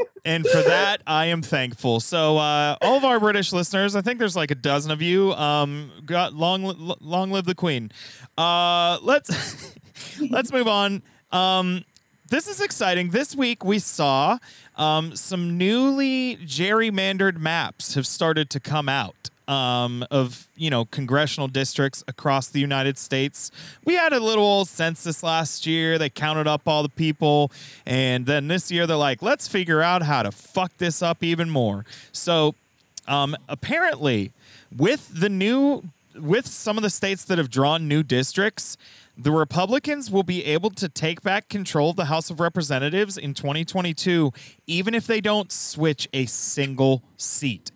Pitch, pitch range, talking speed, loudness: 160 Hz, 140-190 Hz, 165 wpm, -22 LUFS